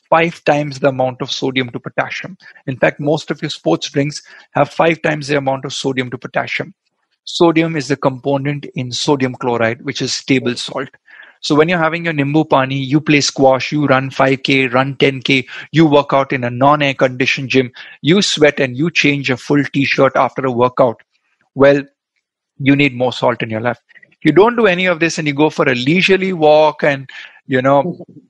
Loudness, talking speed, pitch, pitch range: -15 LUFS, 200 wpm, 140 Hz, 130-155 Hz